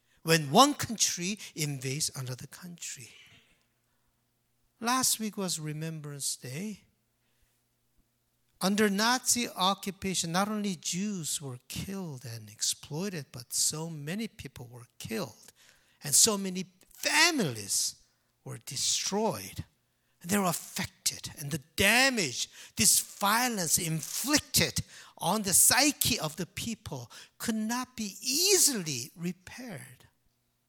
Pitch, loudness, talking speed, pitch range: 165 Hz, -28 LUFS, 105 wpm, 130-205 Hz